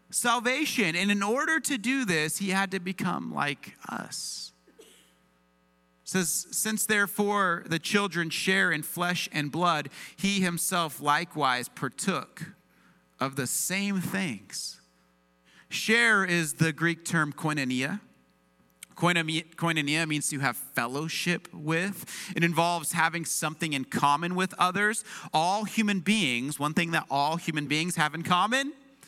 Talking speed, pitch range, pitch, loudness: 130 wpm, 145-195 Hz, 170 Hz, -27 LUFS